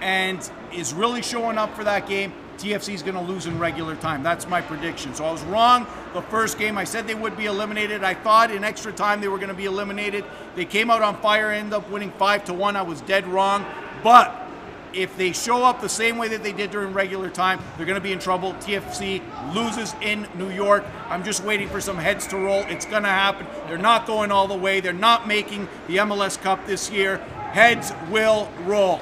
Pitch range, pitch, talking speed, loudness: 190-215 Hz, 200 Hz, 230 wpm, -22 LUFS